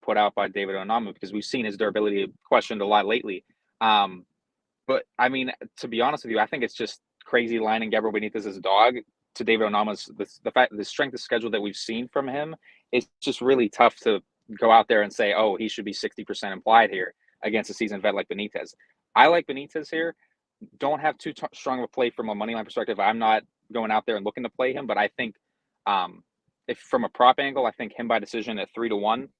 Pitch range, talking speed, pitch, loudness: 105-130 Hz, 240 wpm, 110 Hz, -25 LUFS